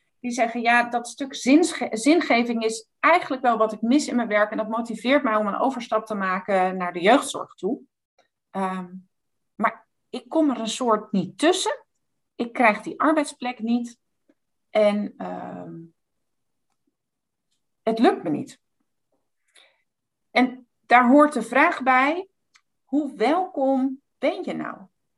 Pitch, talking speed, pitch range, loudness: 240 Hz, 140 wpm, 215-280 Hz, -22 LUFS